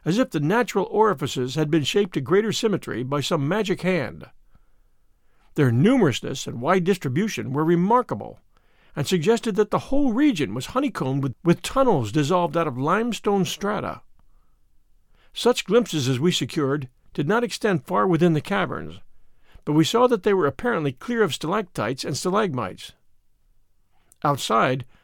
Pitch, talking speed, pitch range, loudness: 175 Hz, 150 wpm, 140-215 Hz, -22 LUFS